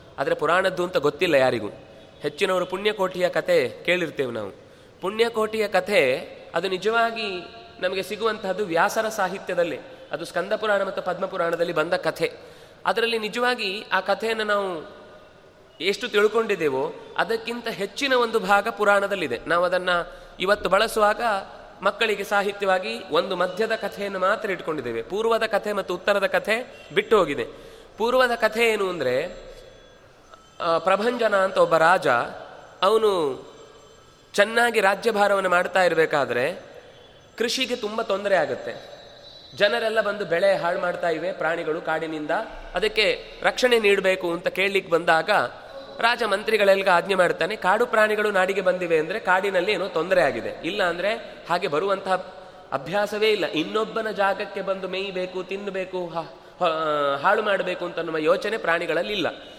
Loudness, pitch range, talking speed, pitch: -23 LUFS, 180-225 Hz, 115 wpm, 200 Hz